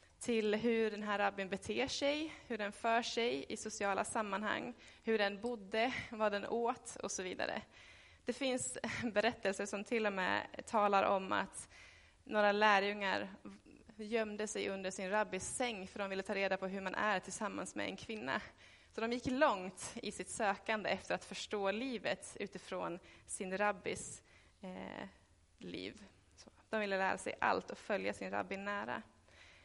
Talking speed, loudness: 160 wpm, -38 LUFS